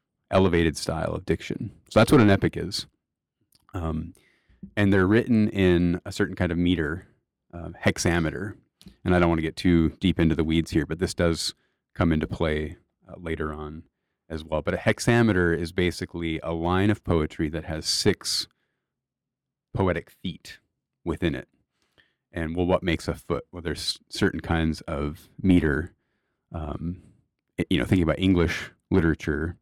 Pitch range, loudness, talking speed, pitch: 80-95 Hz, -25 LUFS, 160 wpm, 85 Hz